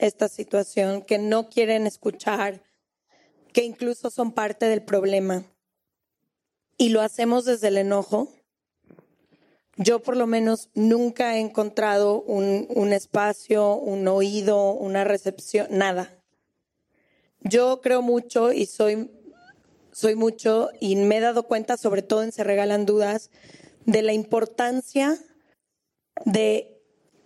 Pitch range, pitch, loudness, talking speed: 205-235 Hz, 215 Hz, -23 LUFS, 120 wpm